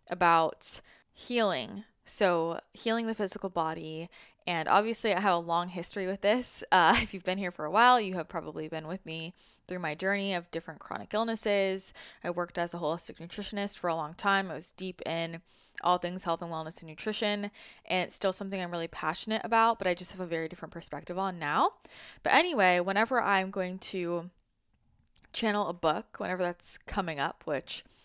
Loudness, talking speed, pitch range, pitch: -30 LUFS, 195 wpm, 165-205 Hz, 180 Hz